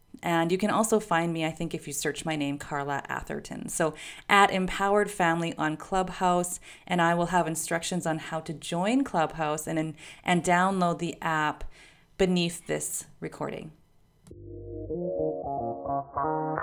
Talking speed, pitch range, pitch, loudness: 140 wpm, 150-180 Hz, 165 Hz, -28 LUFS